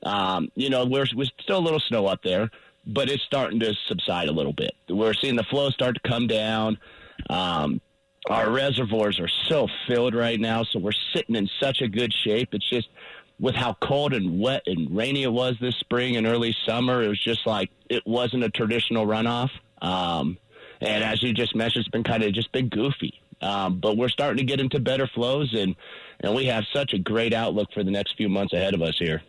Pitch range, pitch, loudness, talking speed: 105-125 Hz, 115 Hz, -25 LUFS, 220 wpm